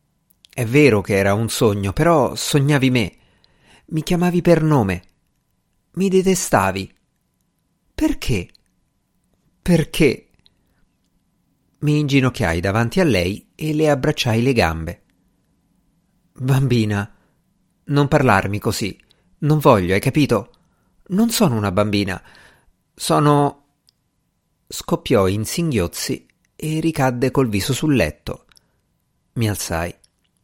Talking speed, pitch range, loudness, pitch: 100 wpm, 95-150 Hz, -18 LUFS, 125 Hz